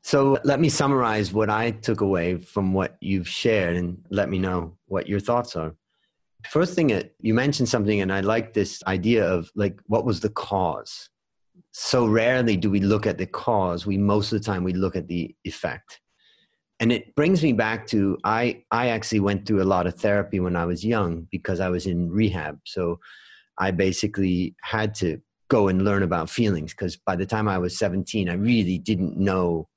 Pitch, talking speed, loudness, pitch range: 100 Hz, 200 wpm, -24 LUFS, 90-110 Hz